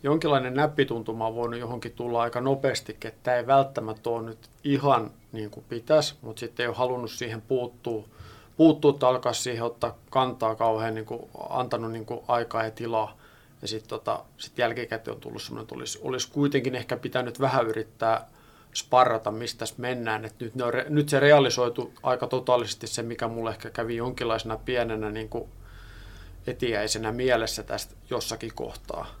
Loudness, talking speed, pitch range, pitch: -27 LUFS, 170 wpm, 110-125 Hz, 120 Hz